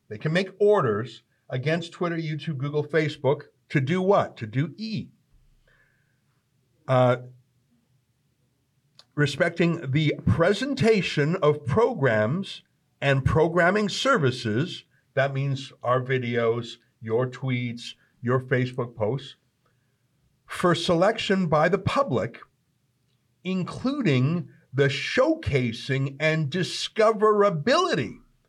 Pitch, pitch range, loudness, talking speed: 140 Hz, 125-165 Hz, -24 LUFS, 90 wpm